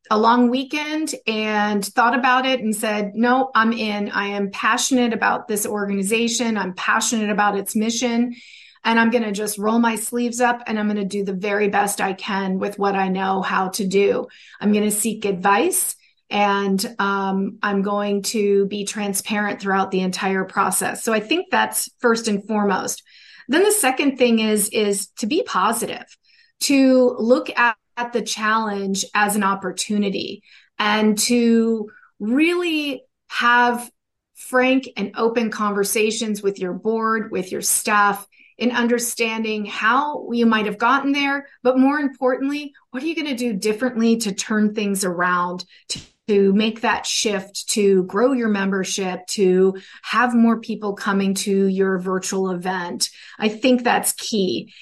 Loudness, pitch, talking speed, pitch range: -20 LUFS, 215 Hz, 160 wpm, 200-240 Hz